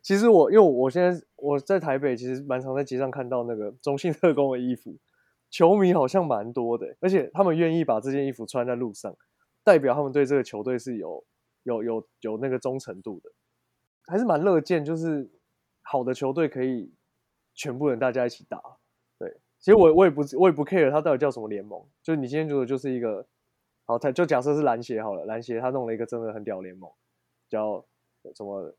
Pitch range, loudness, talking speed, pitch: 120-155 Hz, -24 LUFS, 315 characters per minute, 135 Hz